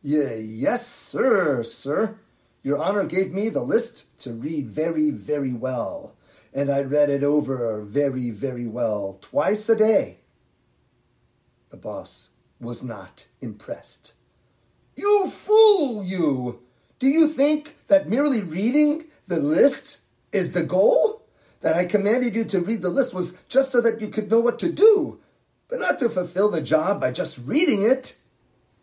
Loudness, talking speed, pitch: -22 LUFS, 150 wpm, 175 Hz